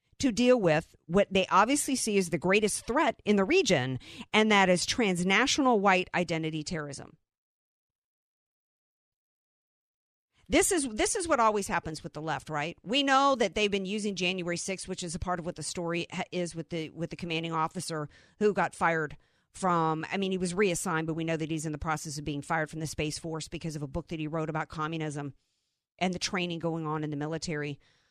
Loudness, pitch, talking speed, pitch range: -29 LUFS, 170 Hz, 205 wpm, 160-195 Hz